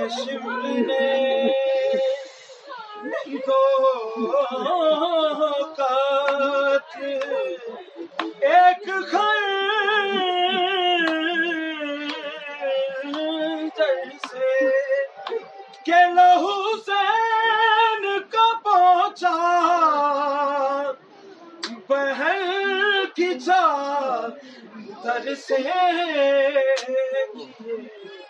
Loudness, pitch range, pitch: -21 LUFS, 270-375 Hz, 310 Hz